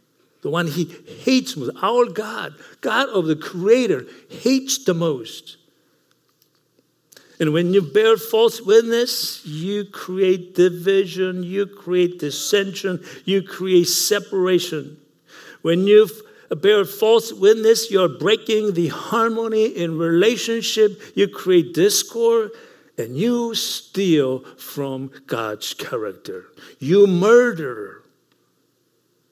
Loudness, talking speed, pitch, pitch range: -19 LUFS, 105 wpm, 200 Hz, 175-235 Hz